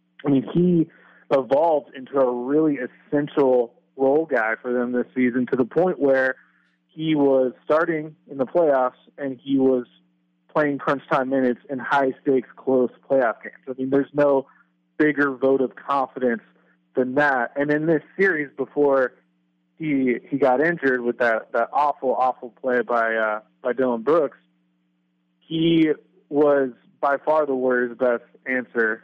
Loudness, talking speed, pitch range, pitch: -22 LUFS, 155 wpm, 125-145 Hz, 130 Hz